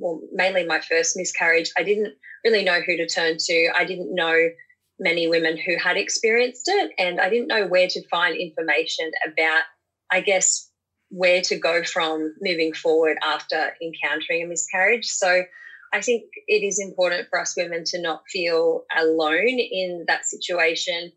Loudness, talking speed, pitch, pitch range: -21 LUFS, 165 wpm, 180 Hz, 165-200 Hz